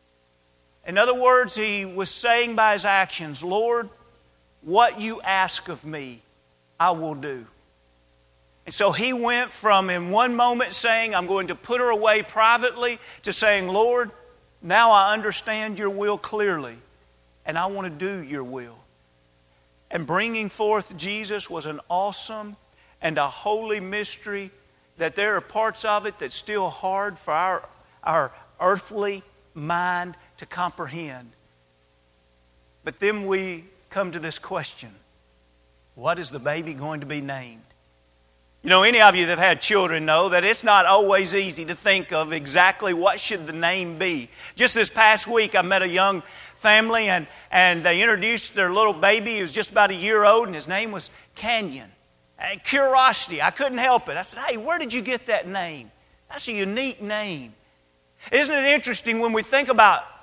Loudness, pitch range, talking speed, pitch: -21 LUFS, 150-215 Hz, 170 wpm, 190 Hz